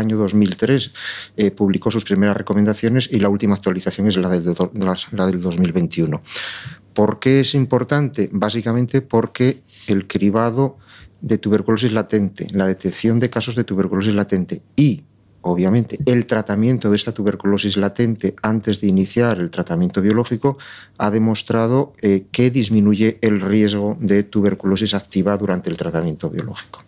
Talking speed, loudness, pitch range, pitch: 145 wpm, -18 LUFS, 100-115 Hz, 105 Hz